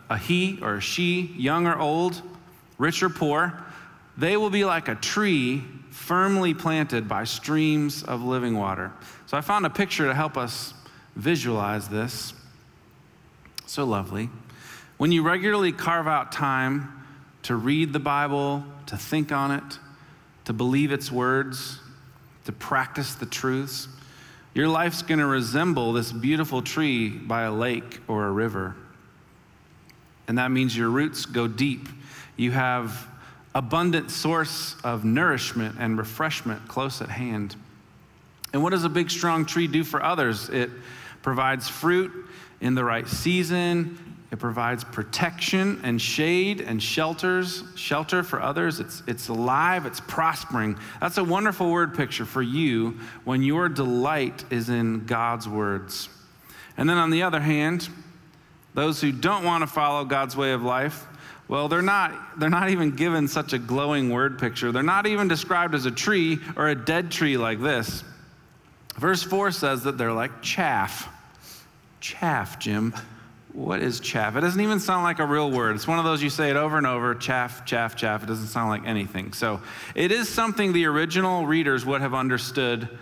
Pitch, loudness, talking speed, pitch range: 140 Hz, -25 LUFS, 165 wpm, 120-165 Hz